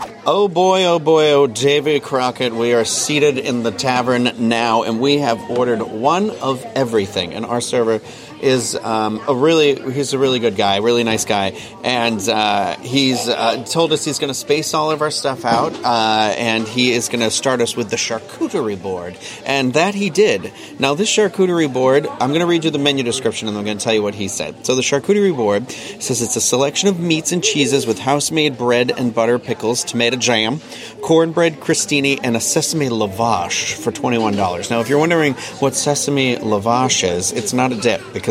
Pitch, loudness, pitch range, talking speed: 130 Hz, -17 LUFS, 115-150 Hz, 205 wpm